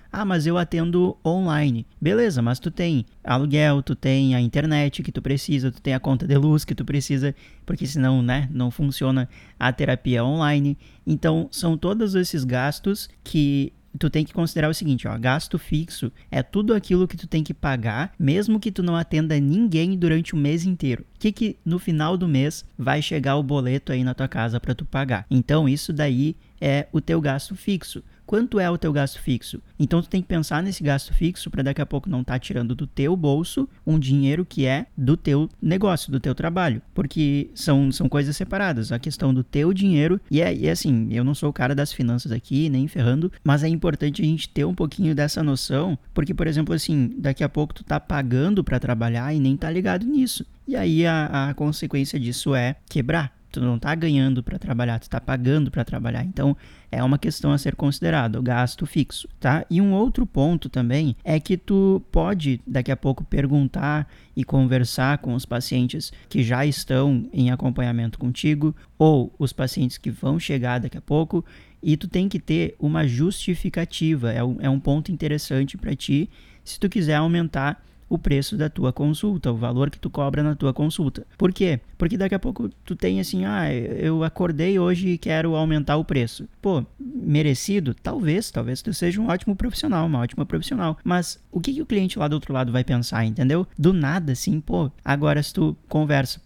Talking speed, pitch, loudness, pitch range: 200 wpm, 150 Hz, -23 LUFS, 135-170 Hz